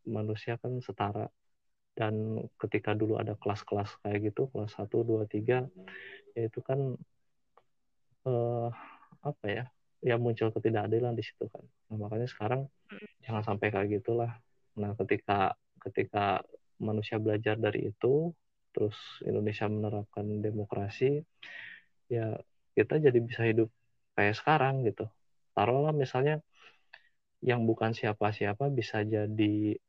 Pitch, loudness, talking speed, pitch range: 110 Hz, -32 LUFS, 120 wpm, 105-125 Hz